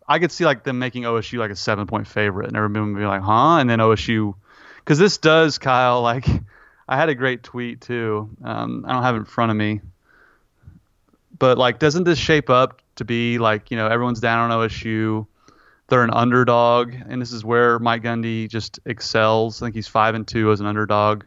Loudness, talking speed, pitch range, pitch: -19 LUFS, 215 wpm, 110-125 Hz, 115 Hz